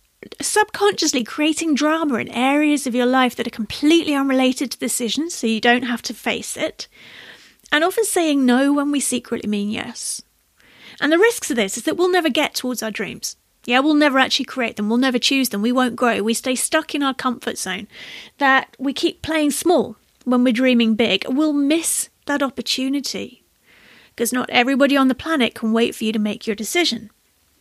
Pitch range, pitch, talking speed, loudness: 235-300 Hz, 260 Hz, 195 wpm, -19 LUFS